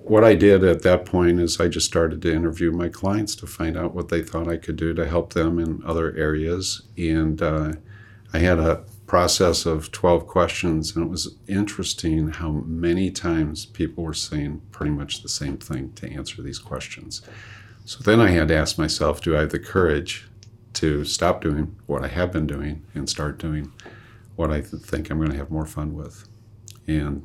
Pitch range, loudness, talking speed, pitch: 80-100 Hz, -22 LUFS, 200 wpm, 85 Hz